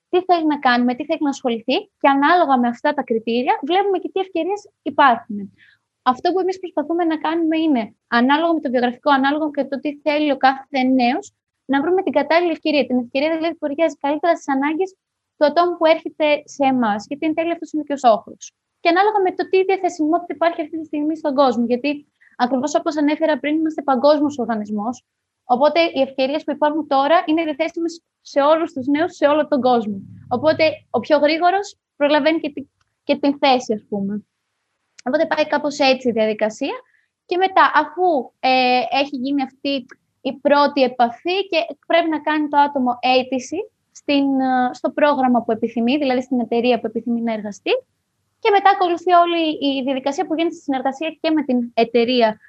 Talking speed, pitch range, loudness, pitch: 185 wpm, 260-330 Hz, -19 LUFS, 295 Hz